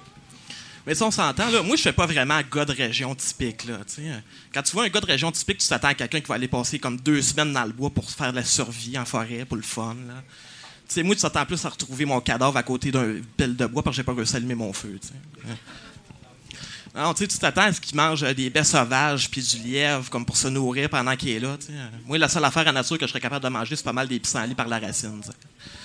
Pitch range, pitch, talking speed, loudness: 120-150 Hz, 135 Hz, 275 wpm, -23 LUFS